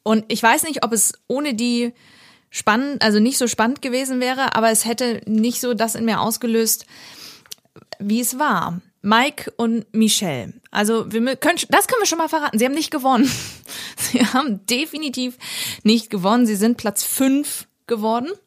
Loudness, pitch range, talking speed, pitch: -19 LUFS, 220-265 Hz, 170 wpm, 235 Hz